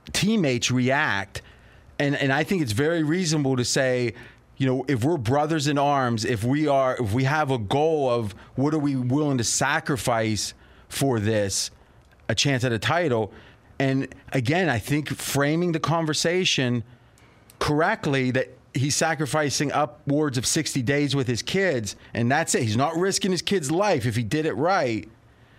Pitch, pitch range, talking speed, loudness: 135 Hz, 120-155 Hz, 170 wpm, -24 LUFS